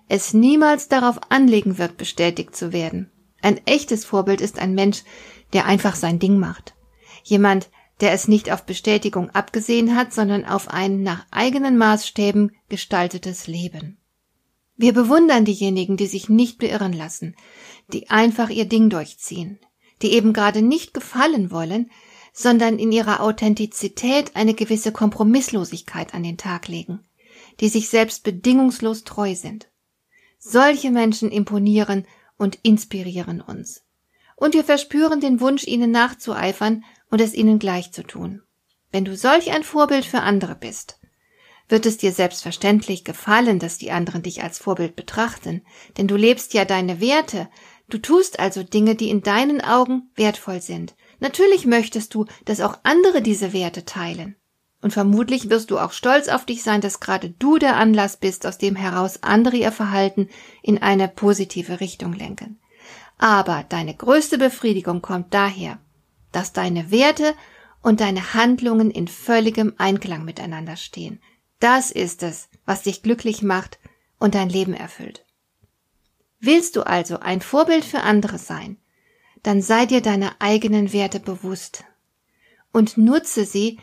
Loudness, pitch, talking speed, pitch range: -19 LUFS, 210 Hz, 150 wpm, 190-235 Hz